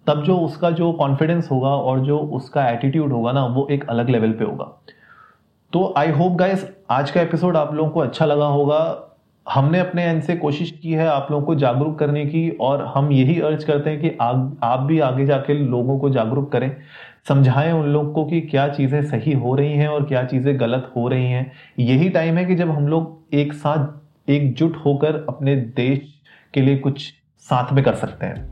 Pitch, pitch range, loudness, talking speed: 145 Hz, 135-160 Hz, -19 LUFS, 210 wpm